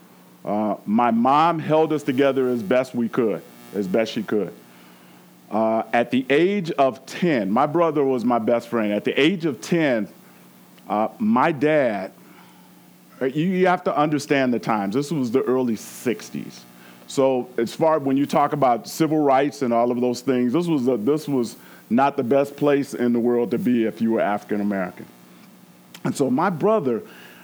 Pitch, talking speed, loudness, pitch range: 125 Hz, 180 wpm, -21 LUFS, 100-140 Hz